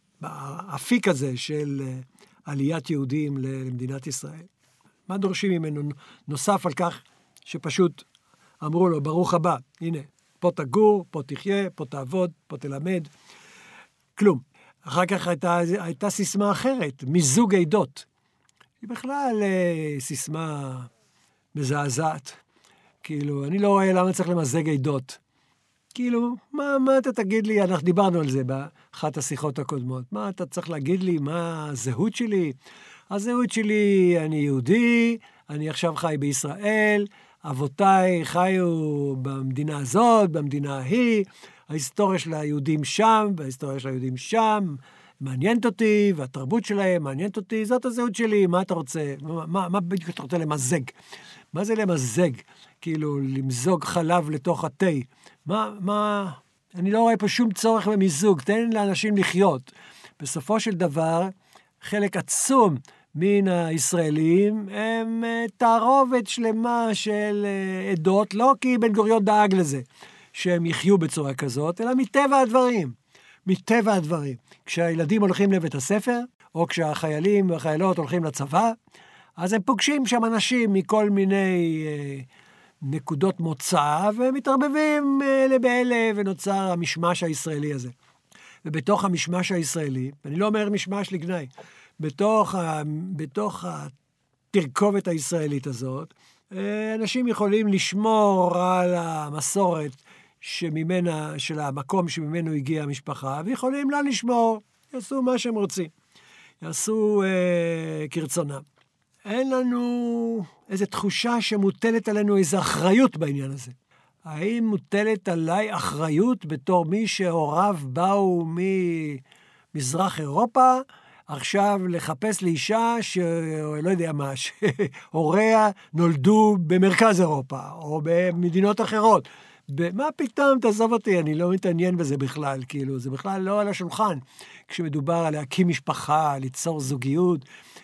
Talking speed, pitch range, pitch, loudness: 120 wpm, 150-210 Hz, 180 Hz, -24 LUFS